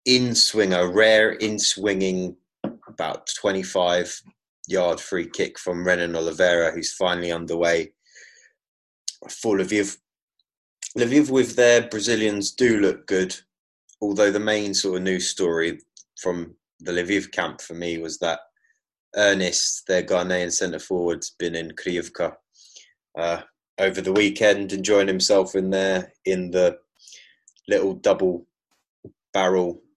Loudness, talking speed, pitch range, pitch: -22 LUFS, 125 wpm, 90-105 Hz, 95 Hz